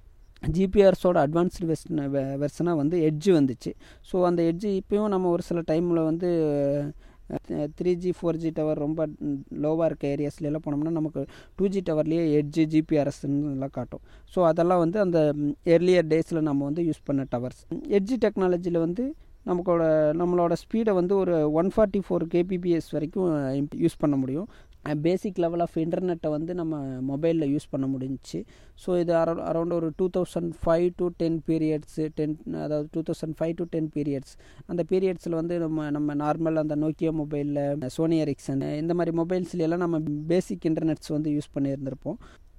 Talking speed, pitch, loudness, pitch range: 155 wpm, 160 Hz, -26 LUFS, 150-175 Hz